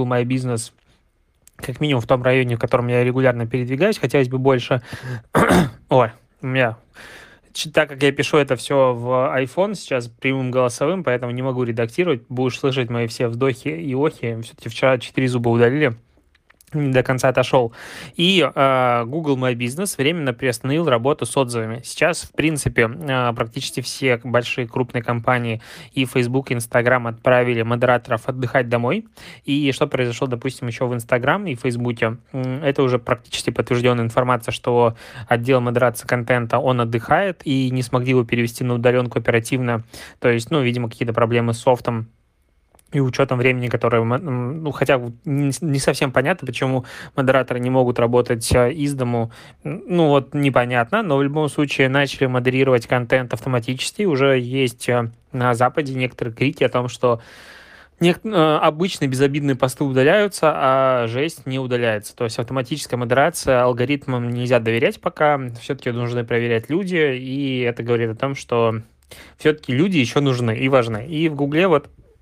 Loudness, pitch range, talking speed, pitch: -19 LUFS, 120-140 Hz, 155 wpm, 130 Hz